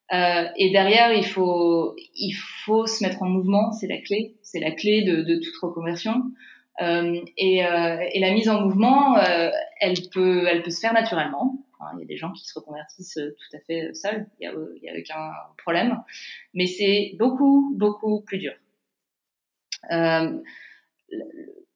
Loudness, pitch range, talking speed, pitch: -22 LUFS, 170-220 Hz, 160 wpm, 190 Hz